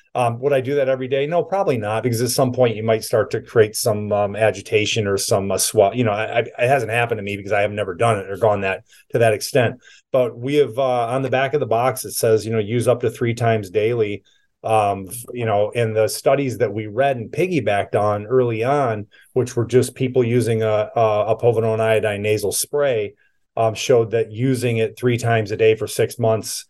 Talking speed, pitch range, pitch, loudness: 235 wpm, 110-130 Hz, 115 Hz, -19 LUFS